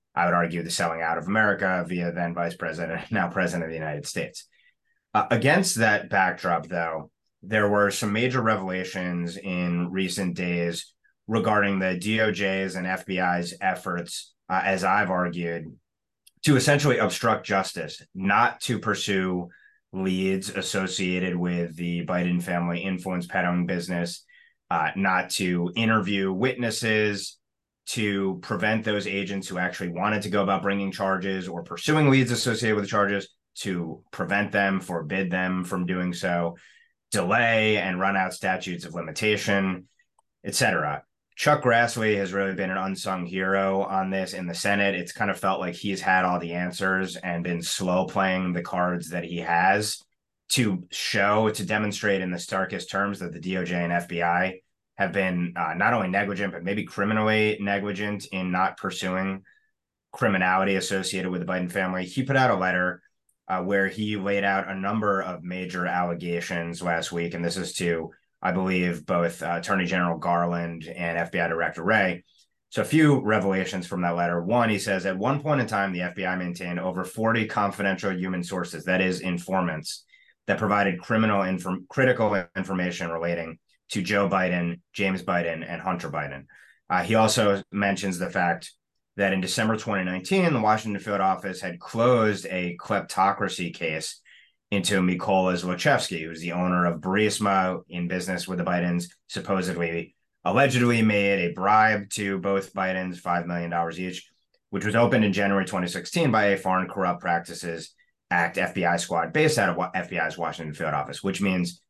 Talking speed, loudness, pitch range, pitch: 160 wpm, -25 LUFS, 90-100 Hz, 95 Hz